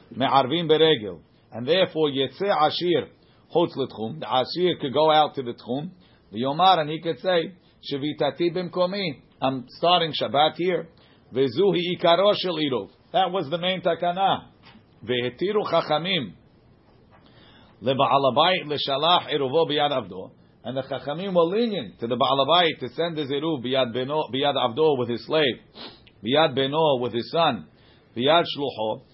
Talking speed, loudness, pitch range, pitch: 140 wpm, -23 LUFS, 130-175 Hz, 150 Hz